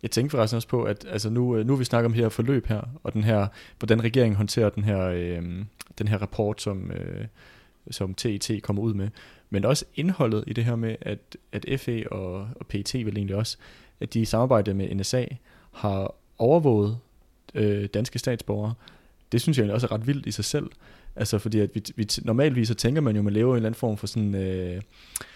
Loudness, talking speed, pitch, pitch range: -26 LUFS, 220 wpm, 110 Hz, 105-120 Hz